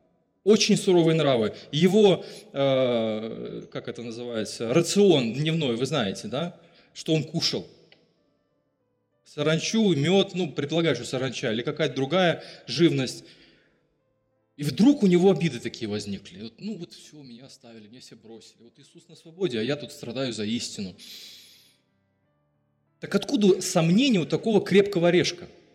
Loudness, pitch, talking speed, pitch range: -24 LUFS, 150 Hz, 135 wpm, 120-180 Hz